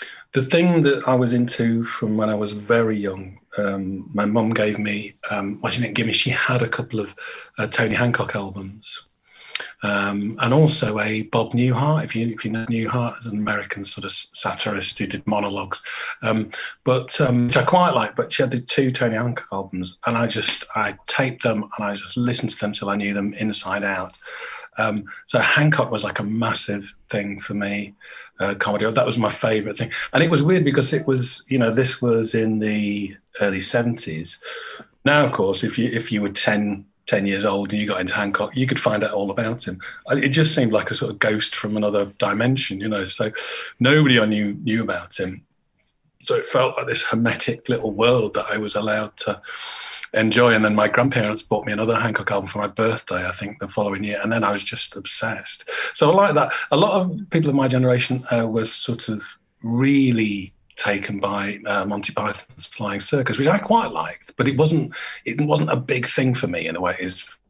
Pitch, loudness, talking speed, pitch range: 110 Hz, -21 LUFS, 210 wpm, 105-125 Hz